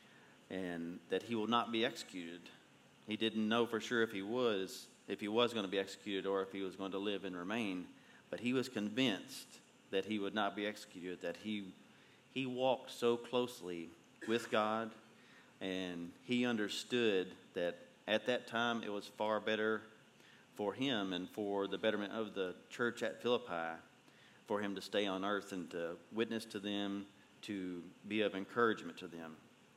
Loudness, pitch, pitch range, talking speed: -39 LUFS, 105 Hz, 95-115 Hz, 175 wpm